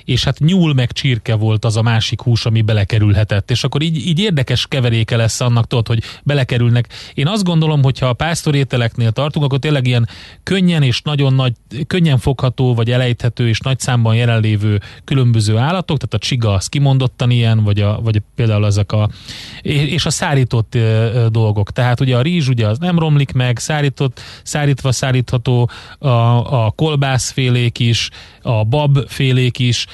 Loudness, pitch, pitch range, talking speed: -15 LUFS, 125 Hz, 115-140 Hz, 165 wpm